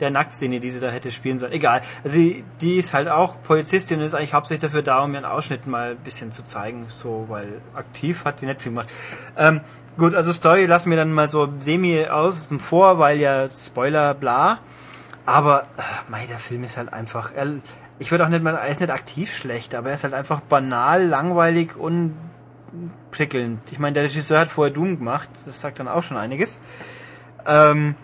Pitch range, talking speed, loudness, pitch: 125-160 Hz, 210 wpm, -20 LUFS, 145 Hz